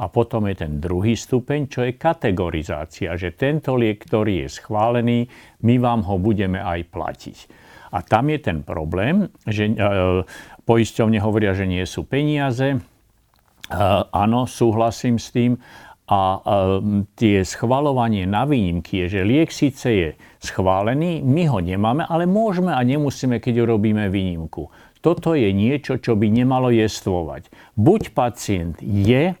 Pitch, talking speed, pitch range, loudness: 110 Hz, 145 wpm, 95-130 Hz, -20 LUFS